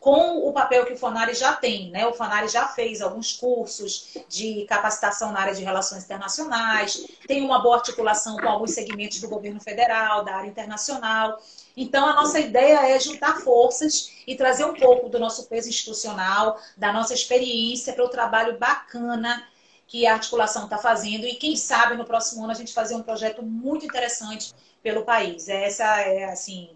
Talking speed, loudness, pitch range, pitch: 180 wpm, -22 LUFS, 215-250 Hz, 230 Hz